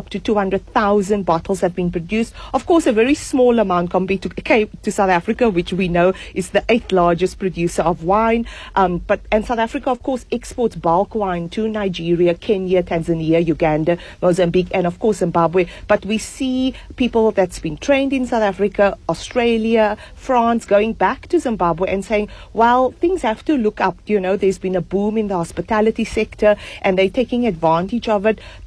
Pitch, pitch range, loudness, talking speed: 205 Hz, 180-230 Hz, -18 LUFS, 185 wpm